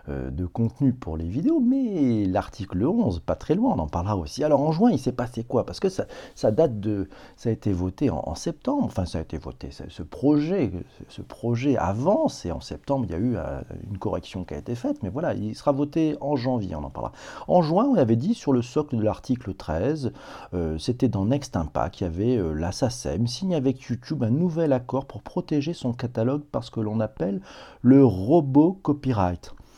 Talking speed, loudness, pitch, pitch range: 220 wpm, -25 LUFS, 120 Hz, 95-145 Hz